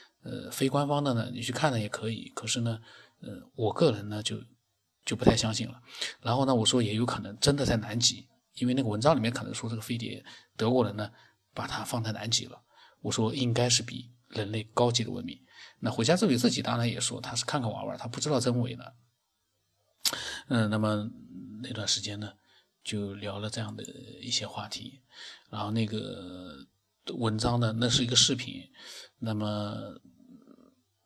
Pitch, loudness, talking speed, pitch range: 120 Hz, -29 LUFS, 270 characters per minute, 110-125 Hz